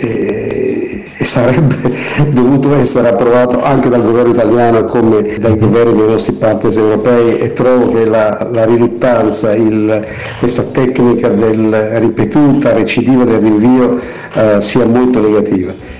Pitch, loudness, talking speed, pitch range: 120 Hz, -10 LUFS, 130 wpm, 110-125 Hz